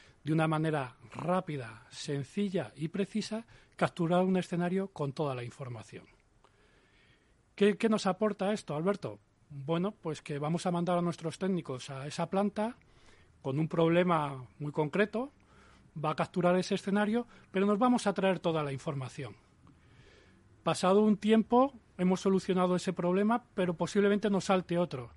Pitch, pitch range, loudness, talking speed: 175 Hz, 145-195 Hz, -31 LUFS, 150 wpm